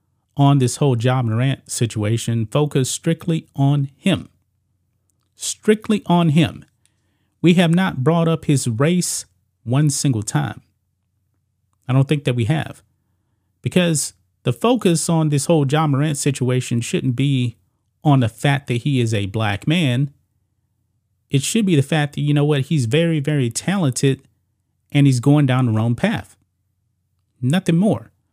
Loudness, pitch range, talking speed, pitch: -19 LUFS, 105-150 Hz, 155 wpm, 130 Hz